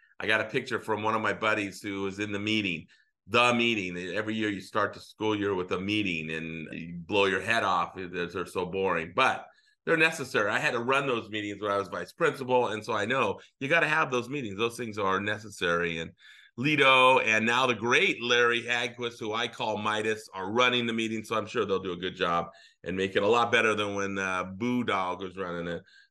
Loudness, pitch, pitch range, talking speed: -27 LUFS, 105 Hz, 95-120 Hz, 230 wpm